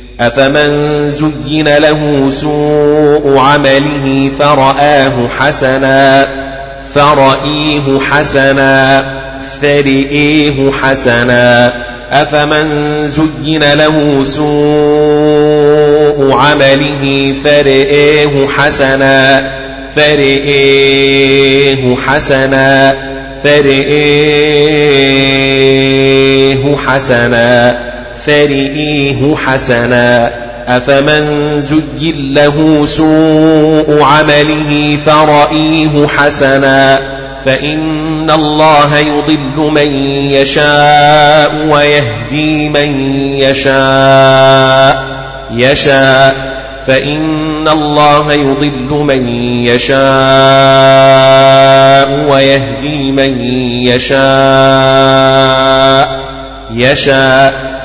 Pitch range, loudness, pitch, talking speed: 135-150 Hz, -7 LUFS, 135 Hz, 50 wpm